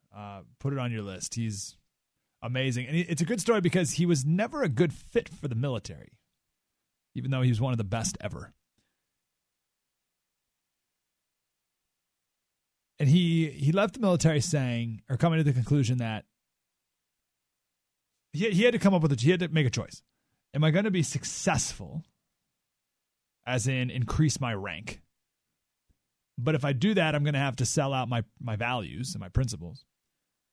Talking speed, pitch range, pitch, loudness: 175 wpm, 100-160 Hz, 130 Hz, -28 LUFS